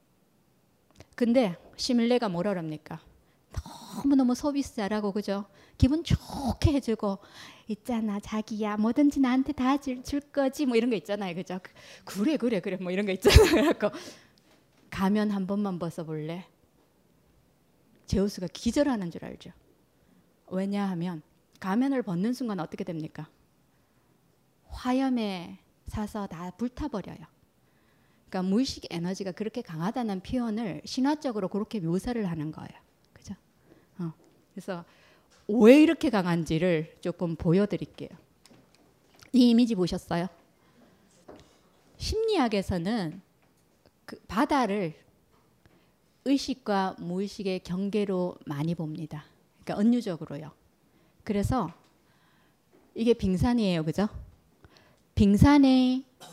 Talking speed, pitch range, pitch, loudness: 255 characters per minute, 180-245 Hz, 200 Hz, -28 LUFS